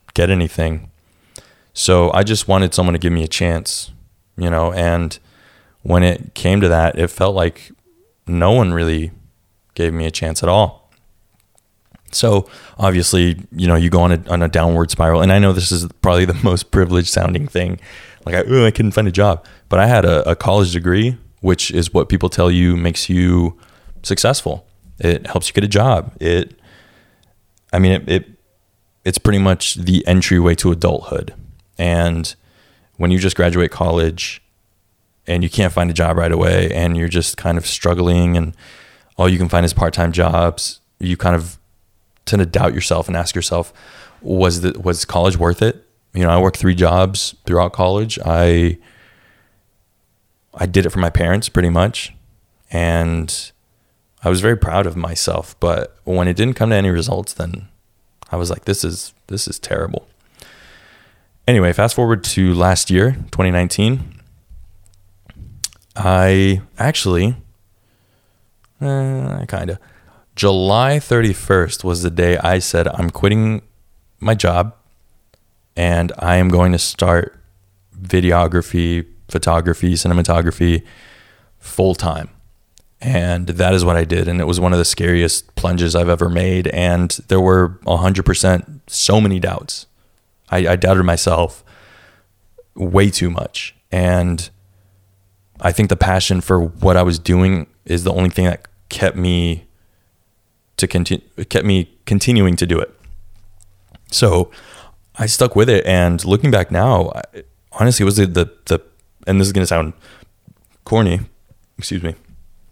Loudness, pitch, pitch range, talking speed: -16 LUFS, 90 Hz, 85-100 Hz, 160 wpm